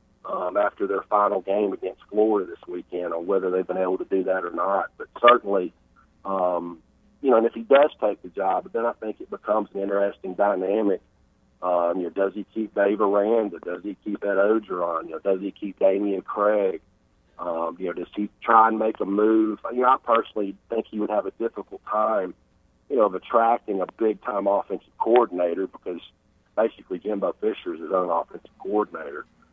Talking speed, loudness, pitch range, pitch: 205 wpm, -24 LUFS, 95-115 Hz, 100 Hz